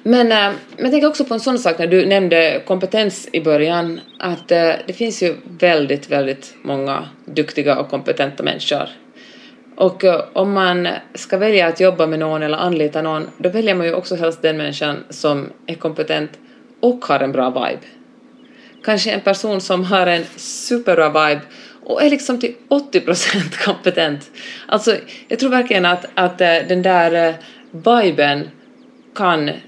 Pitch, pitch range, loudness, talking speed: 185 Hz, 160-230 Hz, -17 LUFS, 160 wpm